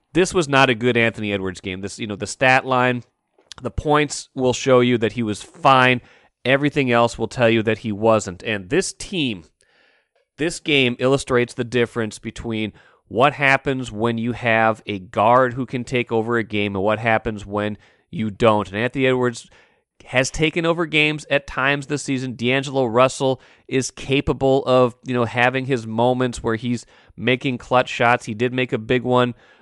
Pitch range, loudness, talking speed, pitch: 115-135 Hz, -20 LUFS, 185 wpm, 125 Hz